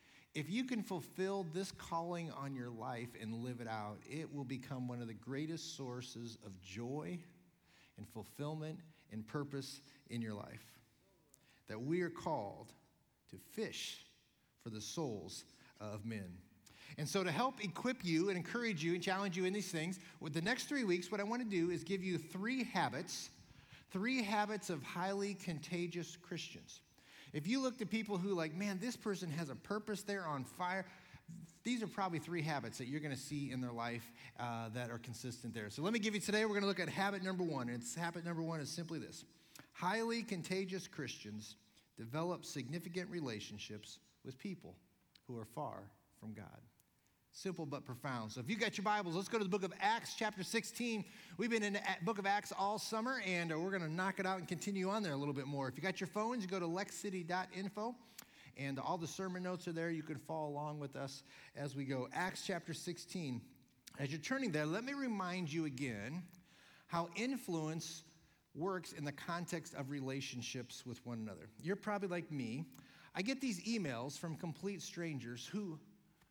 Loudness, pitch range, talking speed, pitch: -42 LUFS, 135-195 Hz, 195 wpm, 170 Hz